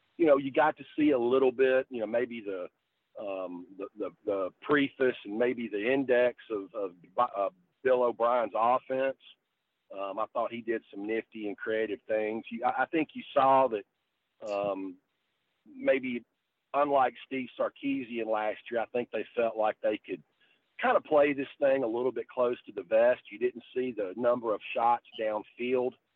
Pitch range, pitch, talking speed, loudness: 110-140 Hz, 125 Hz, 180 wpm, -30 LUFS